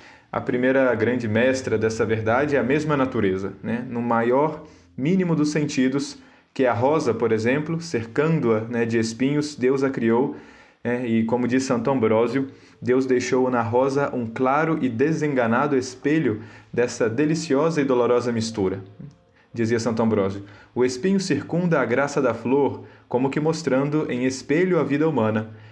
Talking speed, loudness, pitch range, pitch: 155 wpm, -22 LUFS, 115-145 Hz, 125 Hz